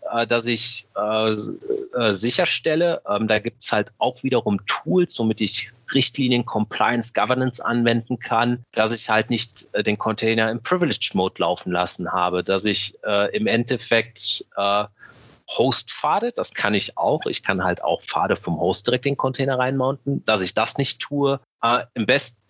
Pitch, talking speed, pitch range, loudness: 115 Hz, 175 wpm, 105-130 Hz, -21 LUFS